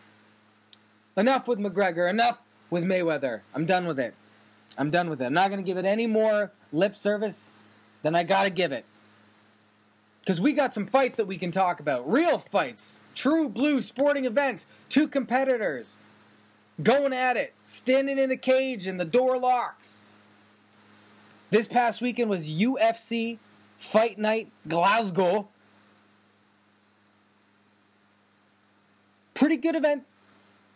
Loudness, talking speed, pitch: -26 LUFS, 135 wpm, 185 Hz